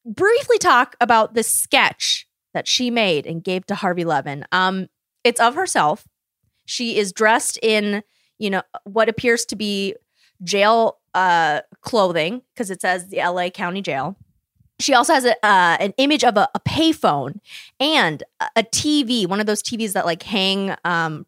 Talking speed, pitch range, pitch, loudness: 165 wpm, 185-240 Hz, 210 Hz, -19 LUFS